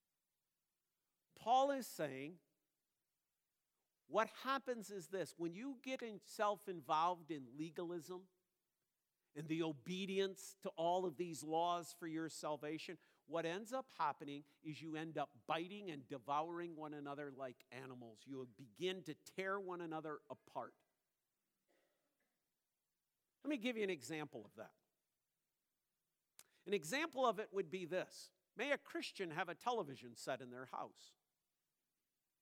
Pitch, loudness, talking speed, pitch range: 170 Hz, -45 LUFS, 135 wpm, 150-195 Hz